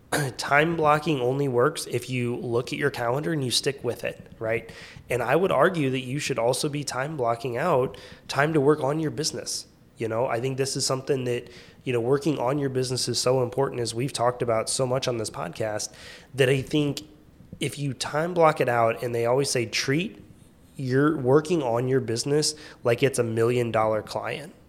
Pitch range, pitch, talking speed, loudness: 120-145 Hz, 130 Hz, 205 wpm, -25 LUFS